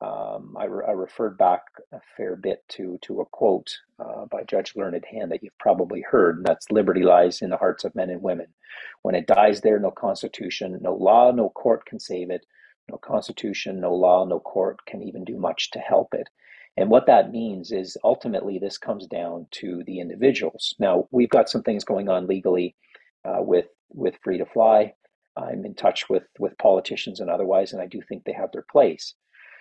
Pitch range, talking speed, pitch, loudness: 90-110 Hz, 205 wpm, 90 Hz, -23 LUFS